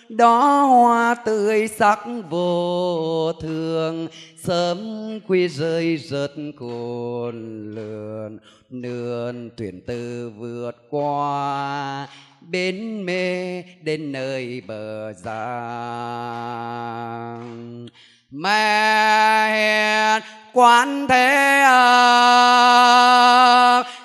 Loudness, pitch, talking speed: -17 LUFS, 160 Hz, 70 wpm